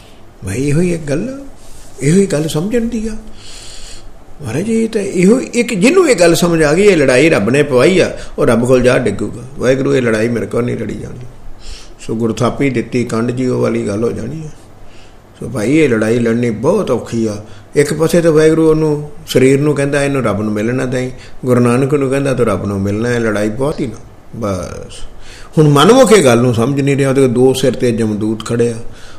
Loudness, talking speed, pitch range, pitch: -13 LUFS, 200 wpm, 110-150 Hz, 125 Hz